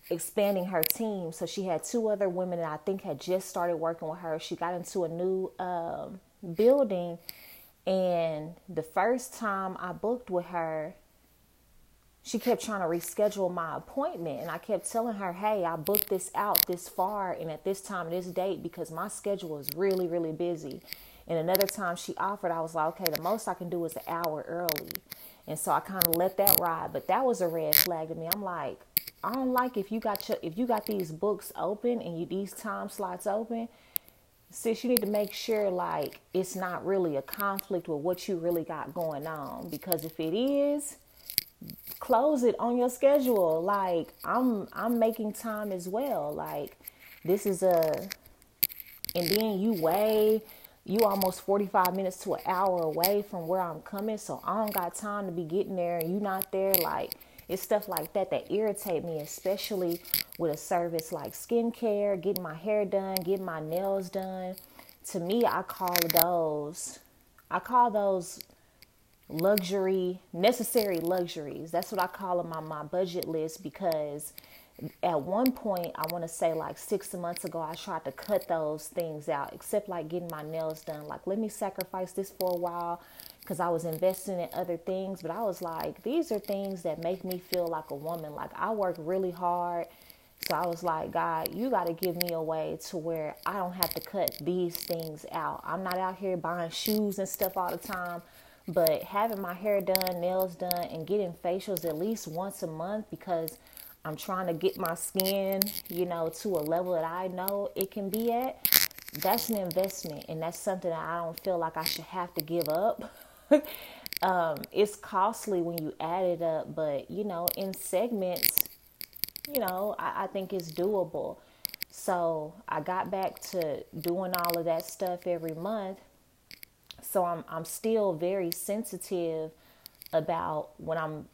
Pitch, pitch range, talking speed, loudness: 185 Hz, 170-200 Hz, 190 wpm, -31 LUFS